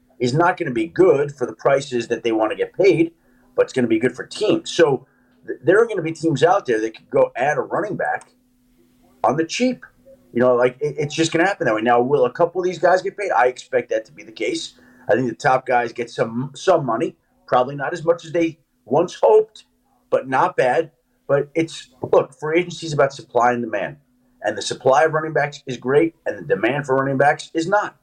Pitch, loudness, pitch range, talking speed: 160 Hz, -20 LUFS, 125-205 Hz, 245 wpm